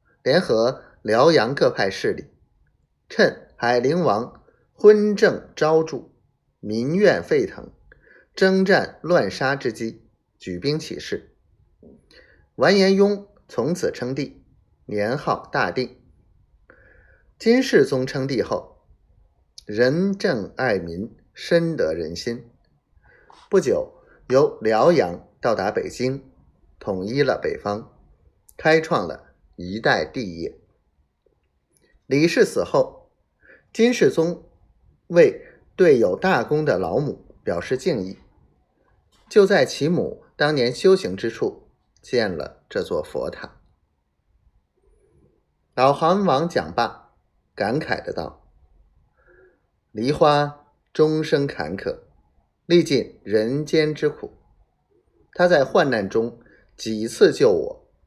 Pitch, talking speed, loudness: 160 Hz, 145 characters per minute, -21 LUFS